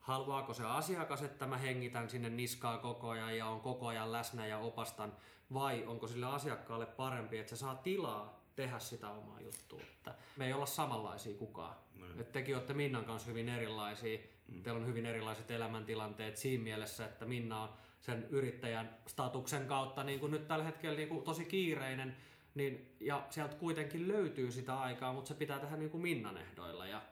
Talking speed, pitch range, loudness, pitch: 175 wpm, 110-140 Hz, -42 LUFS, 120 Hz